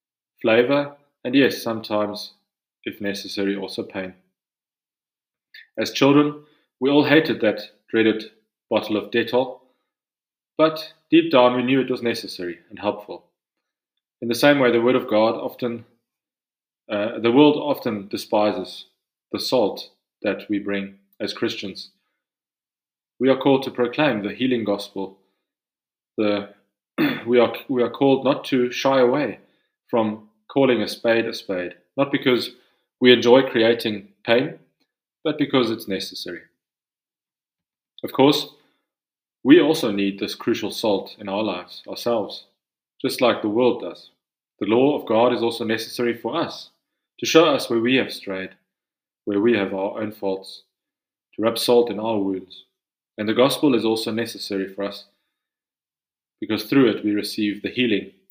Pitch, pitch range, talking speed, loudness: 115 Hz, 100-125 Hz, 145 wpm, -21 LUFS